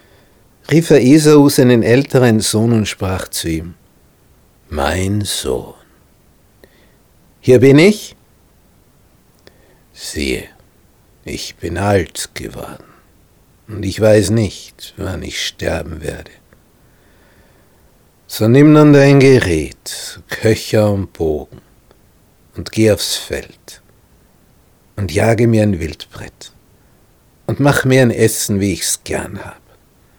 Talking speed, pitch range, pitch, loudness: 105 wpm, 95-125 Hz, 105 Hz, -13 LUFS